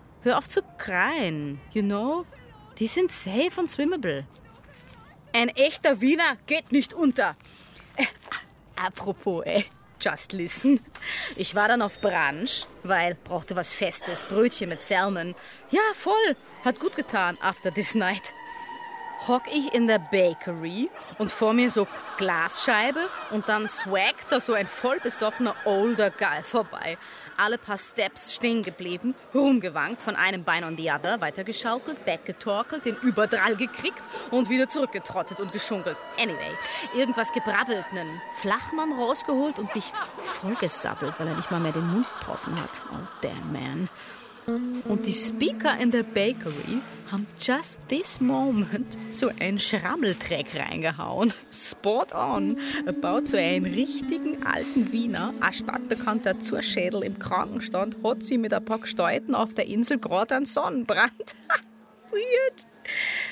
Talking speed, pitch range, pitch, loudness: 140 wpm, 200-275 Hz, 230 Hz, -26 LUFS